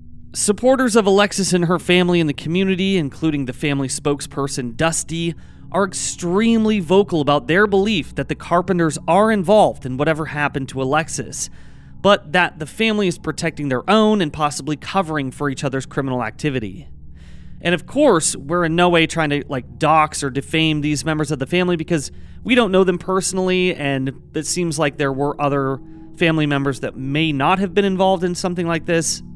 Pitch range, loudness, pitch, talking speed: 140-185 Hz, -18 LUFS, 160 Hz, 180 wpm